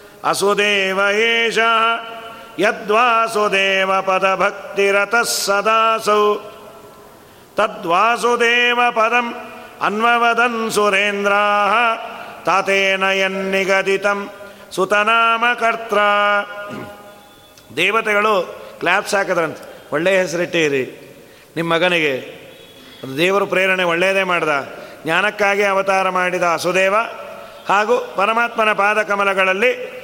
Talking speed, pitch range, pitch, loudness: 60 wpm, 195-230 Hz, 205 Hz, -16 LUFS